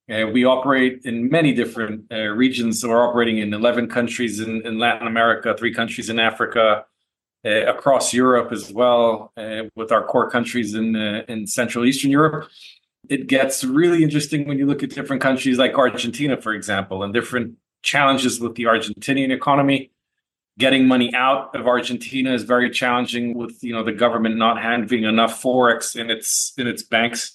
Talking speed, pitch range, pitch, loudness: 180 wpm, 115-130 Hz, 120 Hz, -19 LUFS